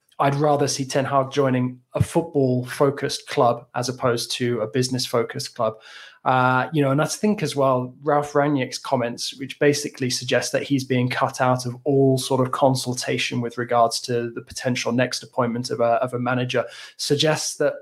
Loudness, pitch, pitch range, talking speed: -22 LUFS, 130 Hz, 125-140 Hz, 185 wpm